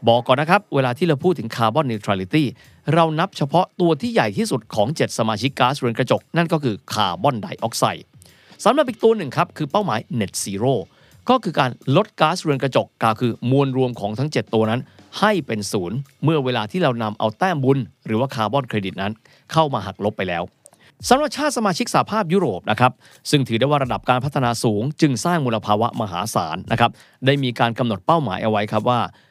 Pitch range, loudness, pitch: 110-155 Hz, -20 LUFS, 130 Hz